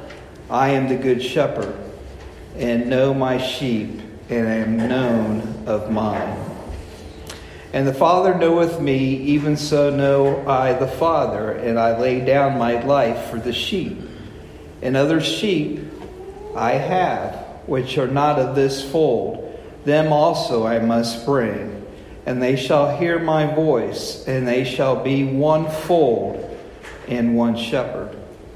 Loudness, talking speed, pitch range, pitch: -19 LUFS, 135 wpm, 115-145 Hz, 130 Hz